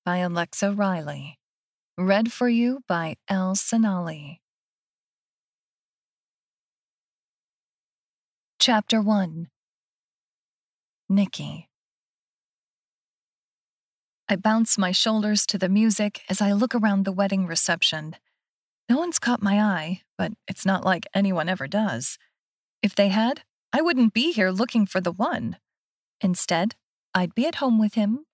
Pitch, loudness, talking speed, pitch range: 200 Hz, -23 LUFS, 120 wpm, 185-220 Hz